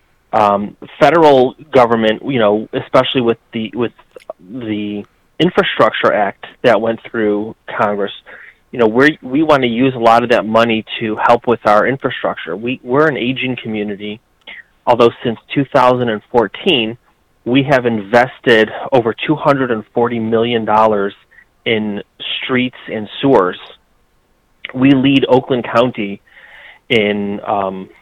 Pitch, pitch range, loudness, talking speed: 115 Hz, 105-130 Hz, -14 LUFS, 120 wpm